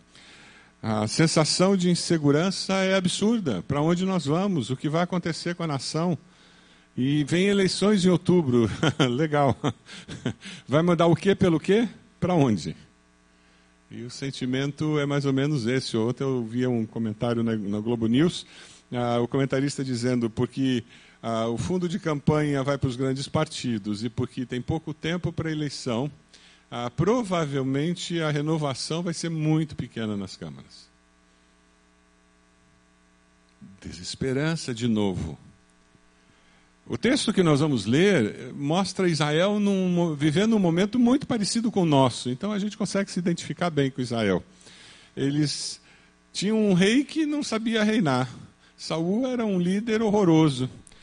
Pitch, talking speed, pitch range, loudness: 145 Hz, 145 wpm, 115-175 Hz, -25 LUFS